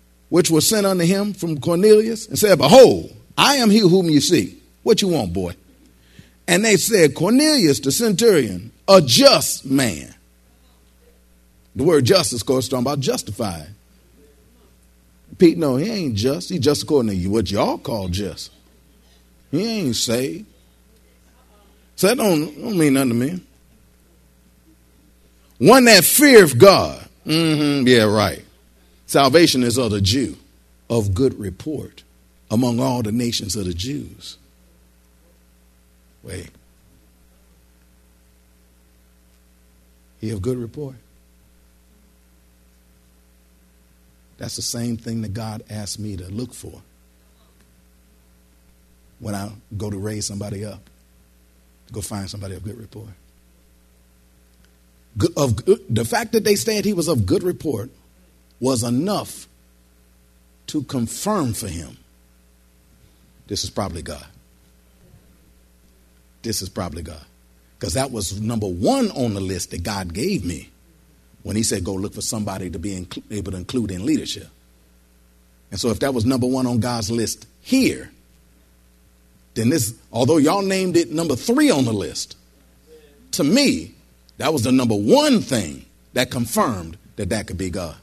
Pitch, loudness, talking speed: 90 Hz, -18 LUFS, 140 wpm